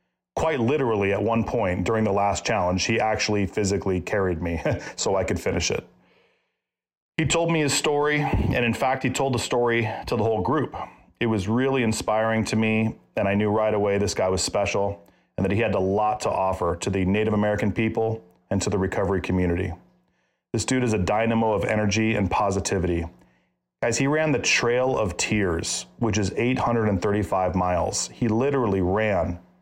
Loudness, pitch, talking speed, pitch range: -24 LUFS, 105 Hz, 185 wpm, 95-115 Hz